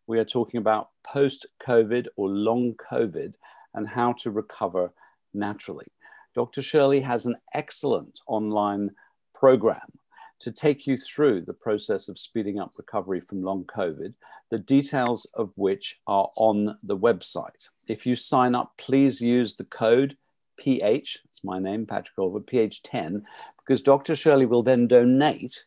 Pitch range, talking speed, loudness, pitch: 105-125 Hz, 145 wpm, -25 LUFS, 120 Hz